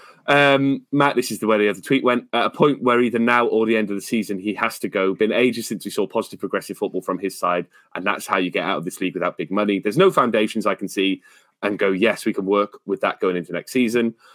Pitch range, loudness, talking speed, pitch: 100-125 Hz, -20 LUFS, 280 wpm, 110 Hz